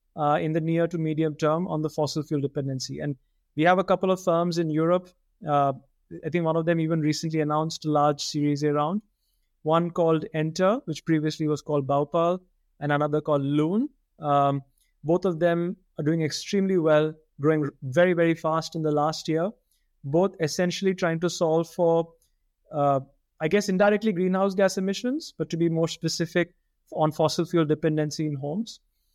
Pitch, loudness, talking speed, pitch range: 160 Hz, -25 LUFS, 175 wpm, 150-175 Hz